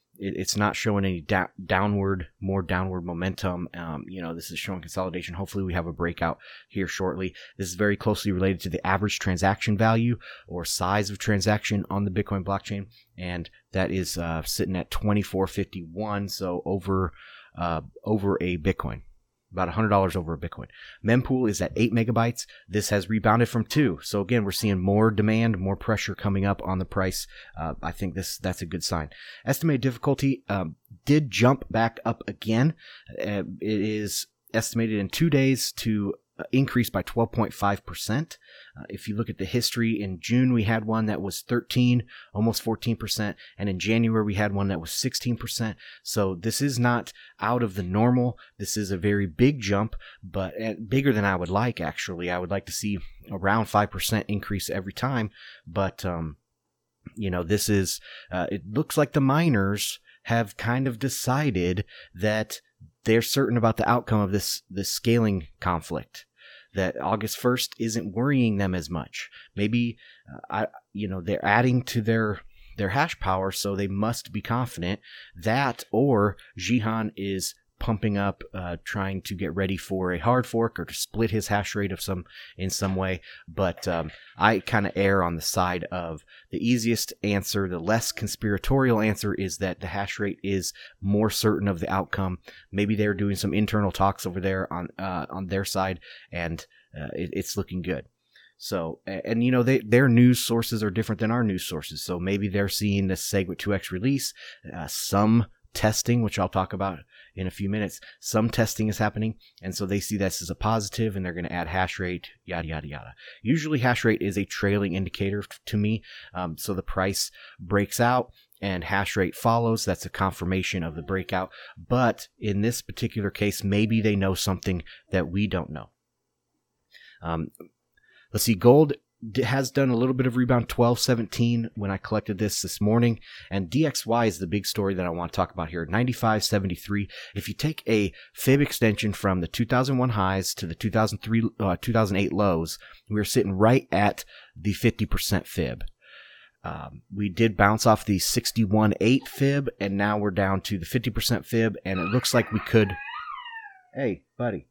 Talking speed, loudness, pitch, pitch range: 185 wpm, -26 LUFS, 100 Hz, 95-115 Hz